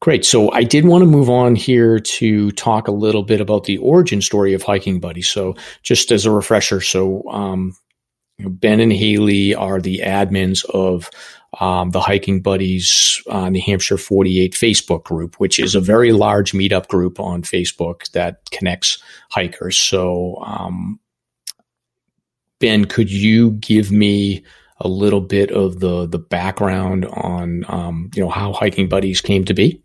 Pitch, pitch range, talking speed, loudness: 100 Hz, 95-105 Hz, 165 wpm, -15 LUFS